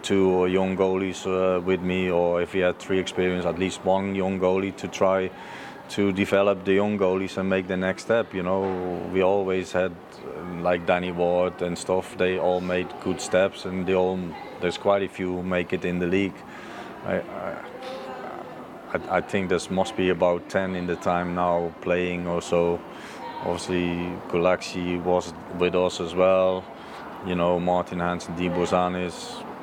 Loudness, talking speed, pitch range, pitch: -25 LUFS, 175 wpm, 90-95 Hz, 90 Hz